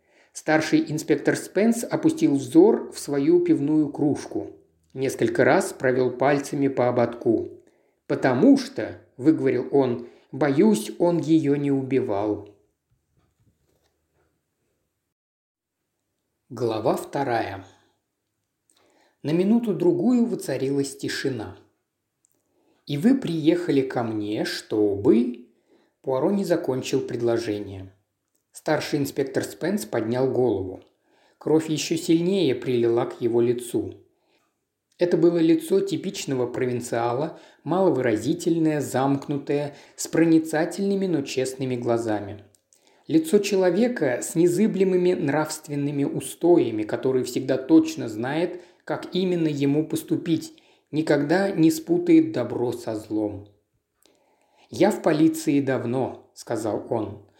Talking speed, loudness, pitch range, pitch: 95 wpm, -23 LUFS, 125-190 Hz, 155 Hz